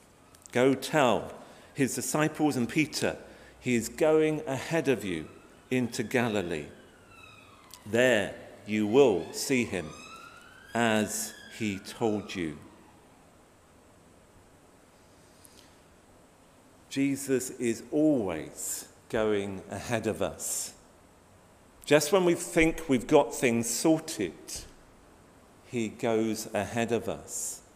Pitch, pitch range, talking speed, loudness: 115 Hz, 95-135 Hz, 95 wpm, -29 LUFS